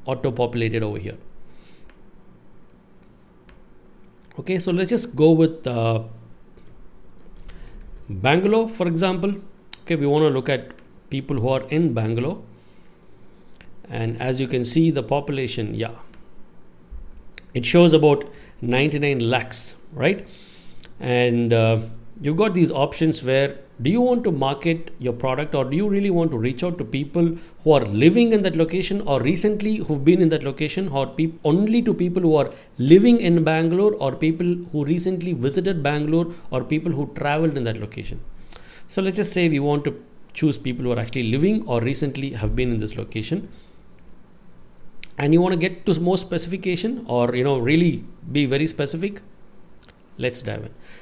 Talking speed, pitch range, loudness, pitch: 160 wpm, 125-175 Hz, -21 LUFS, 150 Hz